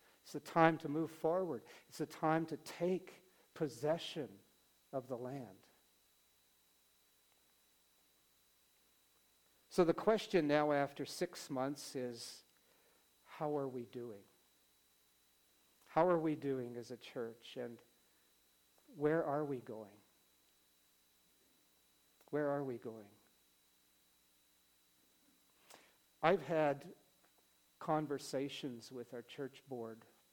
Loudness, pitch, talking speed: -39 LUFS, 115 Hz, 100 wpm